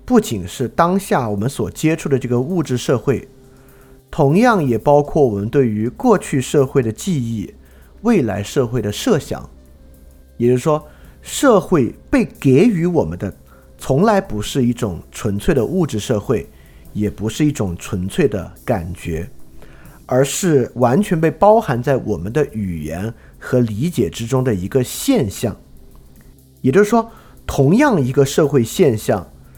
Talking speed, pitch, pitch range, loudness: 225 characters per minute, 125 Hz, 95-145 Hz, -17 LUFS